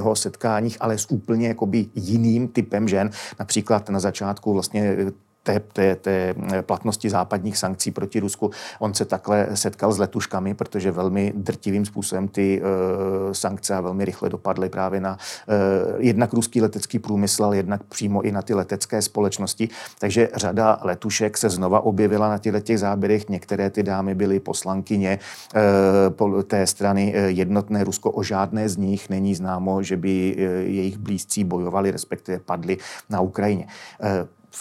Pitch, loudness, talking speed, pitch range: 100 Hz, -22 LUFS, 155 wpm, 95-105 Hz